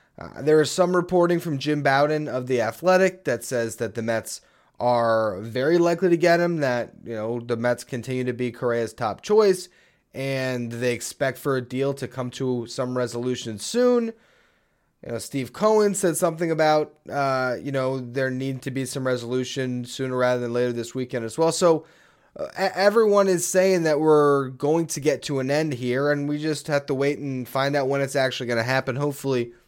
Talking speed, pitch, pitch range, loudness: 200 wpm, 135 Hz, 125-155 Hz, -23 LUFS